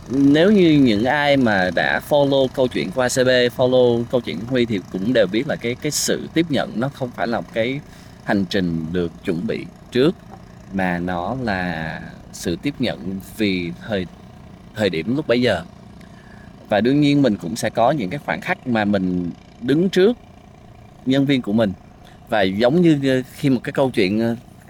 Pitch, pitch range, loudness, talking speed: 120 Hz, 100-140 Hz, -19 LUFS, 190 wpm